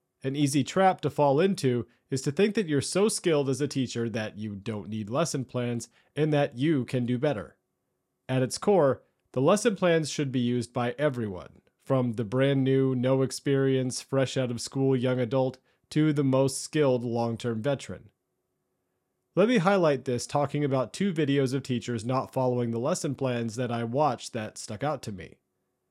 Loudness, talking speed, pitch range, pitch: -27 LUFS, 190 wpm, 120-145 Hz, 130 Hz